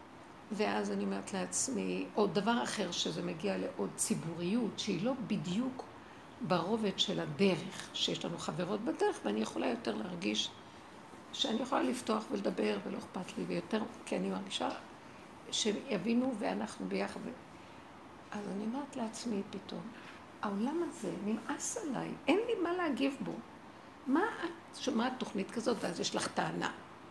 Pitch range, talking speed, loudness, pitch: 190-260 Hz, 135 wpm, -36 LUFS, 220 Hz